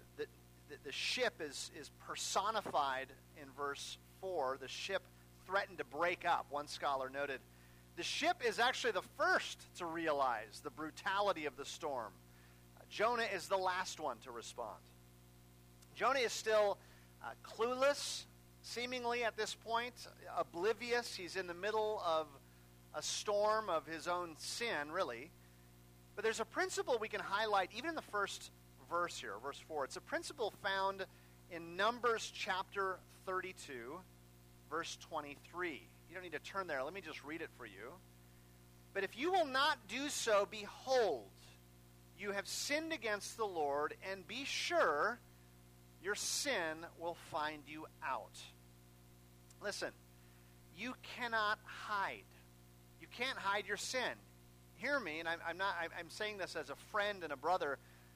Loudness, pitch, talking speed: -40 LUFS, 155 Hz, 150 wpm